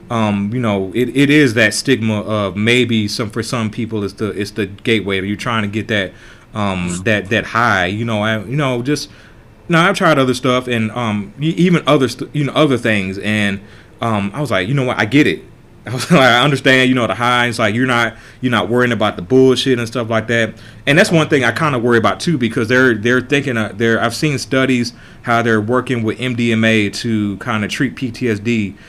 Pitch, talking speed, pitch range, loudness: 115 Hz, 230 wpm, 110-130 Hz, -15 LUFS